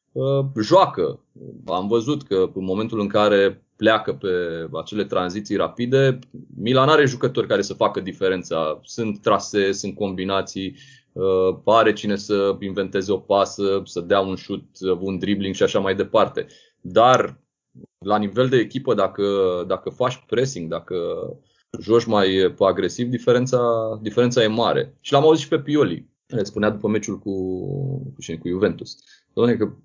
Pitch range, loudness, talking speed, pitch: 95-125 Hz, -21 LUFS, 145 wpm, 105 Hz